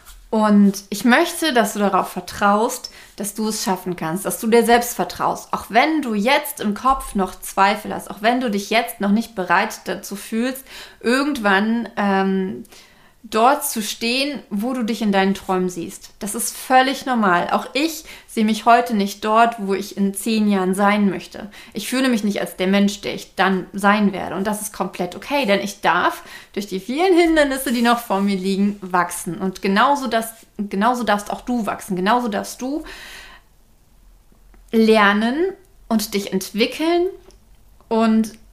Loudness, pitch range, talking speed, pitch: -19 LUFS, 195-240 Hz, 175 wpm, 215 Hz